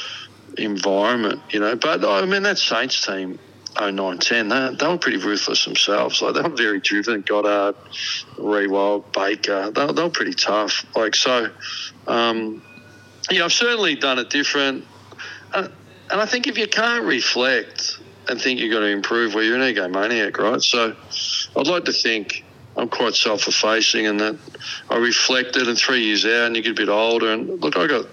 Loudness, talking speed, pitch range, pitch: -19 LUFS, 185 wpm, 105-130 Hz, 115 Hz